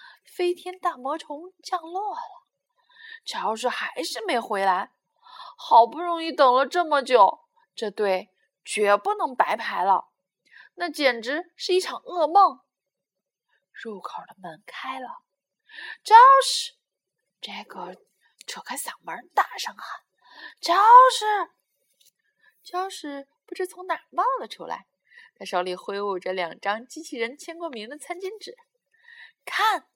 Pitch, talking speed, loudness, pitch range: 350 Hz, 180 characters per minute, -22 LUFS, 265-430 Hz